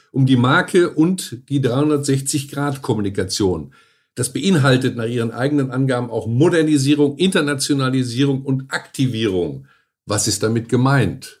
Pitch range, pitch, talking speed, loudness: 120-145 Hz, 135 Hz, 110 wpm, -18 LUFS